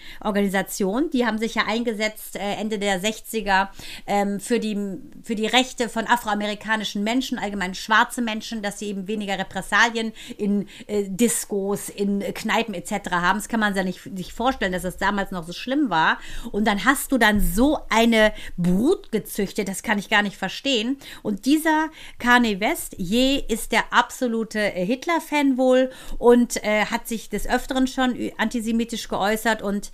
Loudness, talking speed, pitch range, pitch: -22 LUFS, 170 wpm, 200-245 Hz, 220 Hz